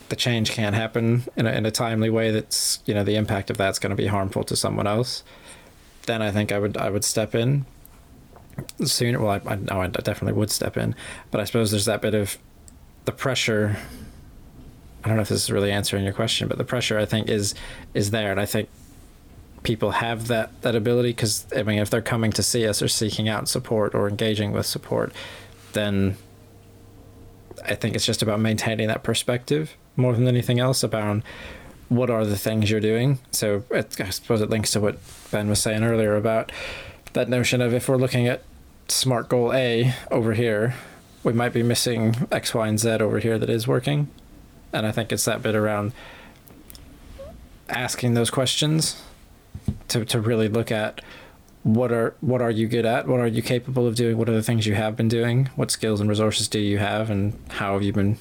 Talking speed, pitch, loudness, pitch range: 205 wpm, 110 Hz, -23 LUFS, 105-120 Hz